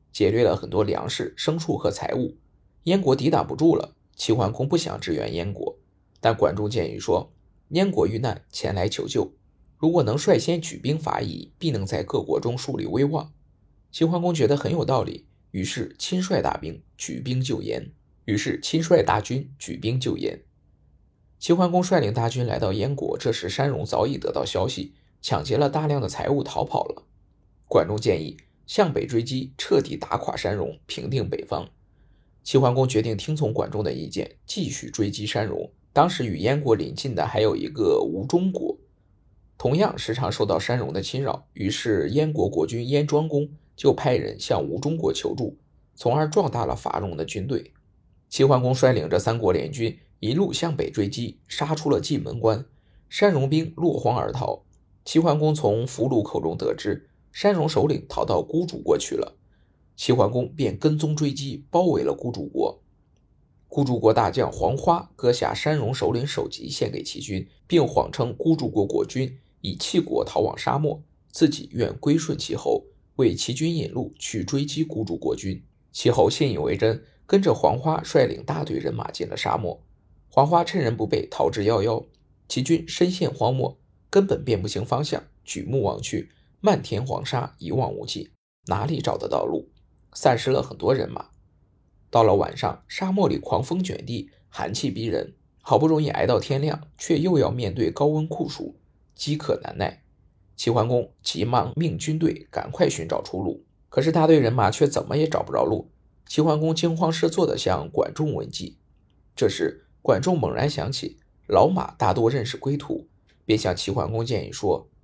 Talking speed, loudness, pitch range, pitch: 260 characters per minute, -24 LUFS, 115-160 Hz, 145 Hz